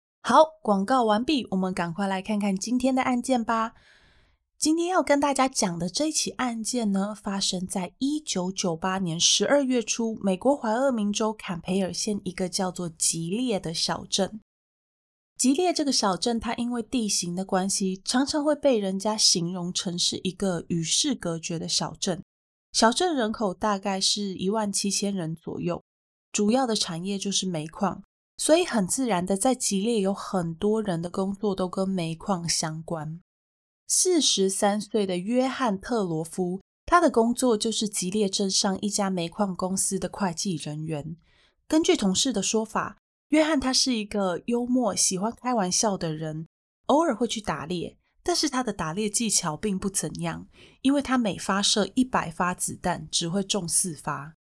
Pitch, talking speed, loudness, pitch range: 200 Hz, 250 characters per minute, -25 LUFS, 185-235 Hz